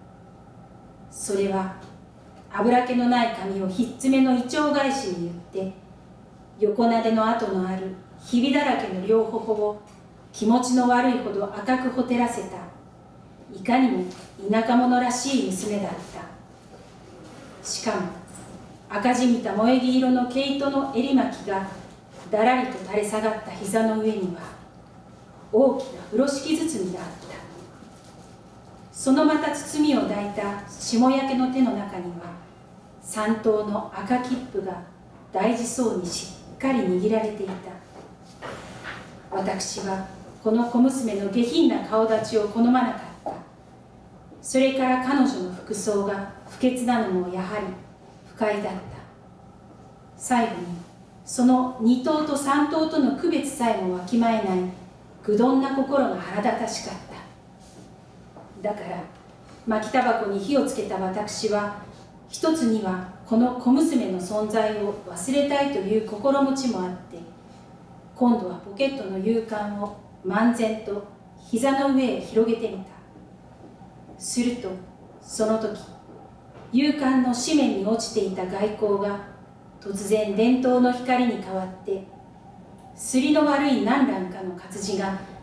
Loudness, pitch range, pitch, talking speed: -24 LUFS, 195-255 Hz, 220 Hz, 240 characters per minute